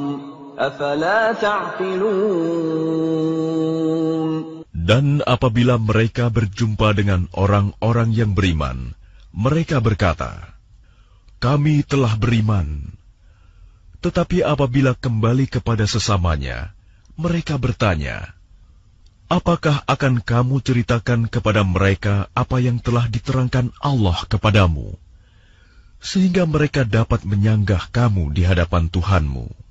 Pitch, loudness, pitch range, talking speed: 115 Hz, -19 LUFS, 95-140 Hz, 80 wpm